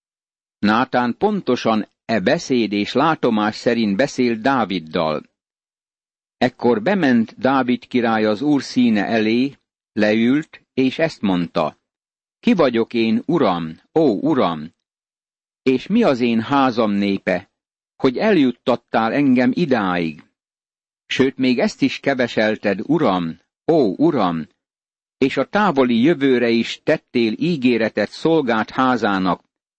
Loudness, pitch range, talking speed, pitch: -18 LUFS, 105-135 Hz, 110 wpm, 120 Hz